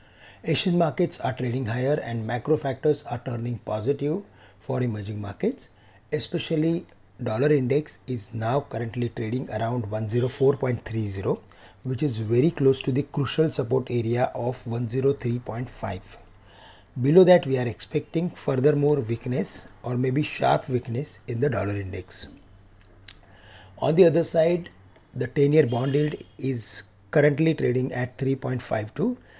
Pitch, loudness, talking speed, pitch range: 125 Hz, -25 LUFS, 130 wpm, 110-145 Hz